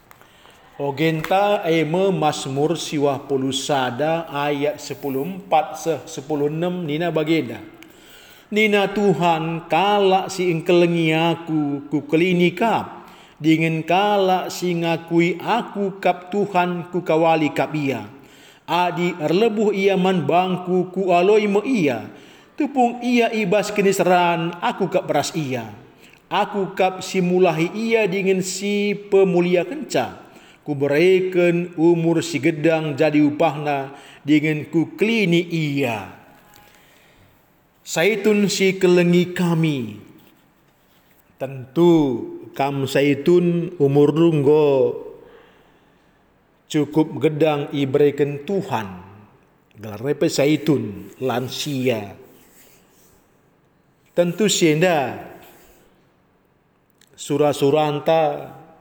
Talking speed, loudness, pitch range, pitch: 90 wpm, -19 LUFS, 150-190 Hz, 165 Hz